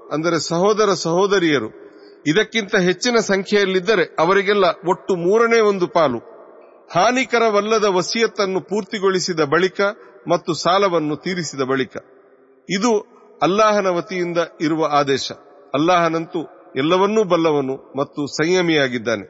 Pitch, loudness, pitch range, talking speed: 185 Hz, -18 LUFS, 160-210 Hz, 90 wpm